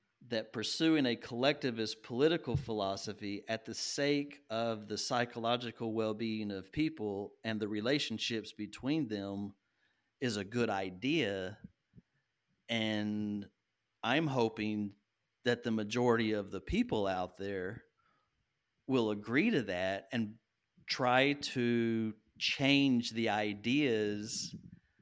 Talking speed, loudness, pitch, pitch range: 110 wpm, -35 LUFS, 110 Hz, 105-120 Hz